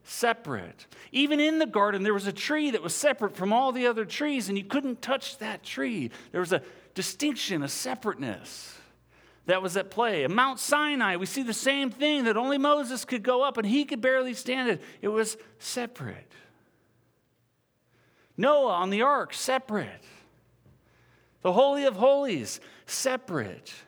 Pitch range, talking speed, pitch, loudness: 205-275 Hz, 165 wpm, 250 Hz, -27 LUFS